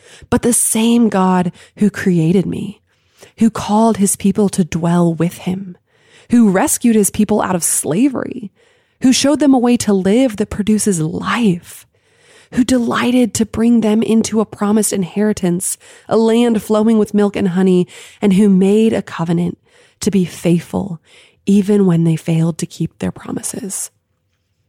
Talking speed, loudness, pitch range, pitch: 155 wpm, -15 LUFS, 180-225 Hz, 205 Hz